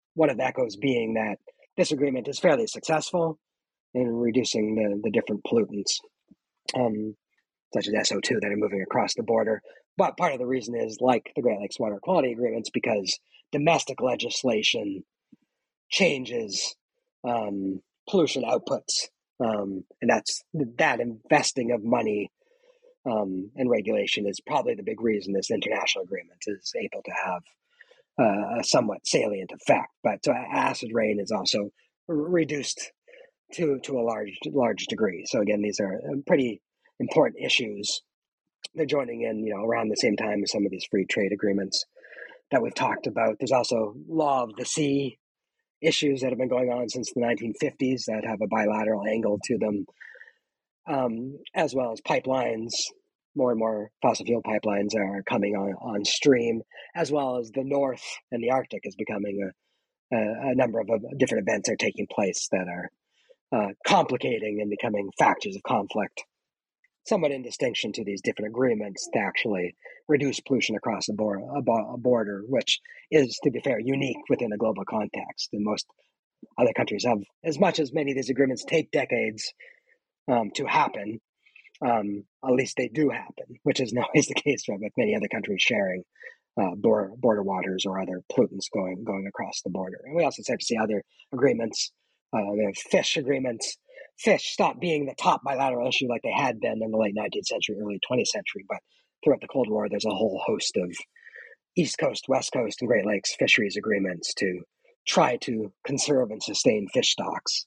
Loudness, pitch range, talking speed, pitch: -26 LUFS, 105-155 Hz, 175 wpm, 125 Hz